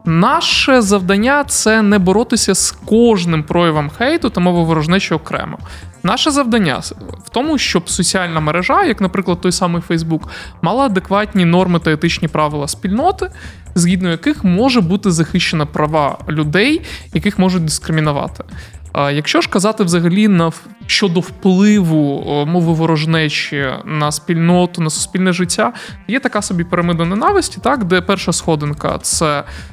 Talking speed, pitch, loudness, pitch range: 135 wpm, 180 Hz, -14 LUFS, 160-210 Hz